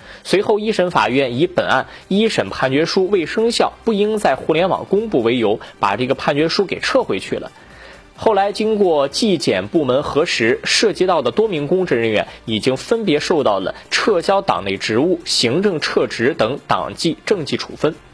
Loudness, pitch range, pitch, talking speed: -17 LUFS, 130-210 Hz, 180 Hz, 270 characters per minute